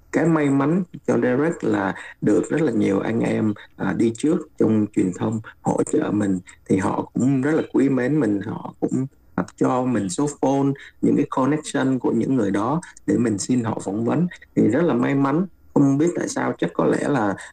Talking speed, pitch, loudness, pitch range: 210 wpm, 135 Hz, -22 LUFS, 110-155 Hz